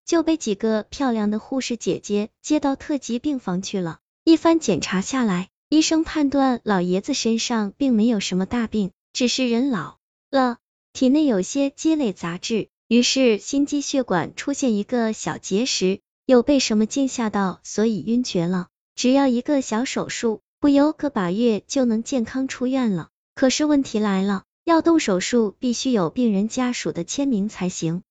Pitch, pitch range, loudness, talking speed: 240 Hz, 205-270 Hz, -21 LUFS, 255 characters per minute